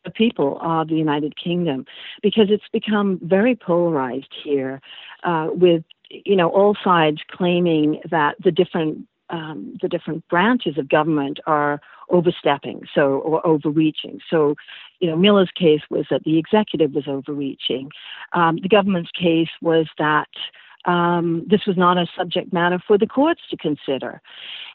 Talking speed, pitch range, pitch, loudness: 155 wpm, 155-185 Hz, 170 Hz, -20 LUFS